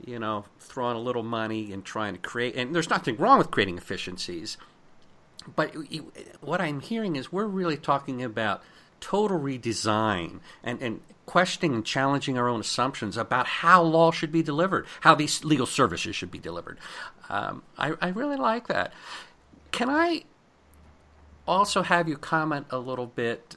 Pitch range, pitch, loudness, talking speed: 115-170 Hz, 135 Hz, -26 LUFS, 165 wpm